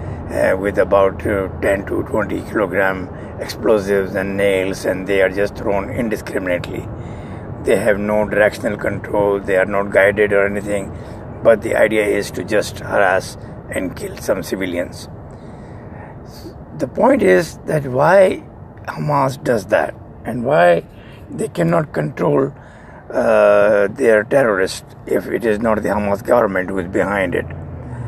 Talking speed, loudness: 140 wpm, -17 LUFS